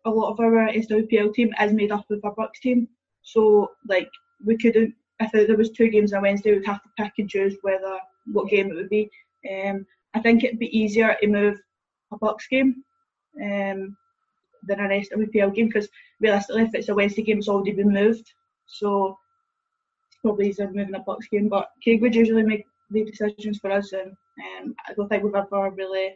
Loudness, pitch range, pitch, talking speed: -23 LUFS, 200-230 Hz, 215 Hz, 215 wpm